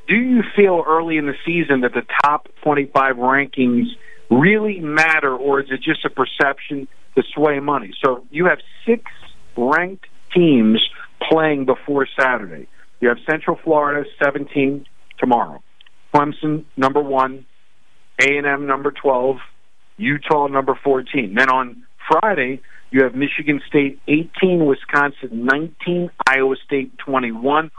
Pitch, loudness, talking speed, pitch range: 145 Hz, -18 LUFS, 130 wpm, 135-155 Hz